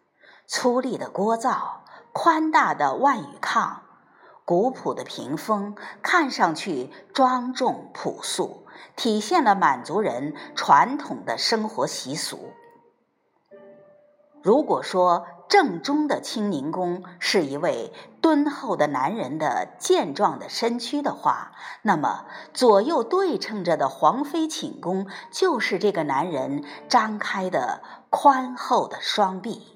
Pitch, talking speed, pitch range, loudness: 255 Hz, 175 characters per minute, 200-310 Hz, -23 LUFS